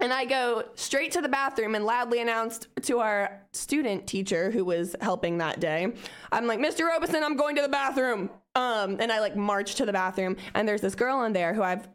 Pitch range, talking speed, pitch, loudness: 195-265 Hz, 220 wpm, 225 Hz, -27 LUFS